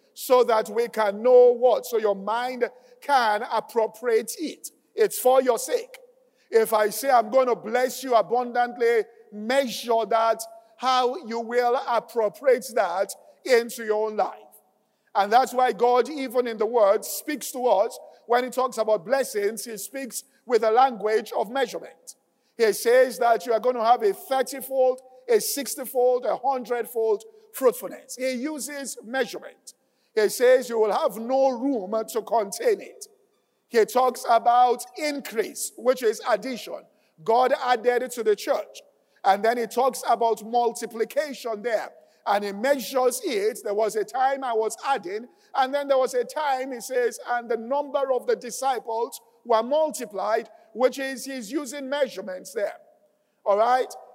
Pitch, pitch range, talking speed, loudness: 250 Hz, 230-280 Hz, 160 wpm, -24 LUFS